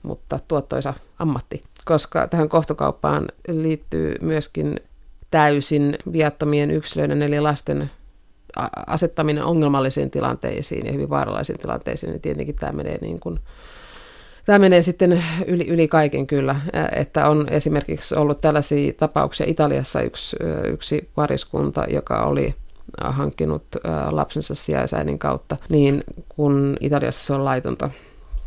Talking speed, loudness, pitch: 115 wpm, -21 LUFS, 145 Hz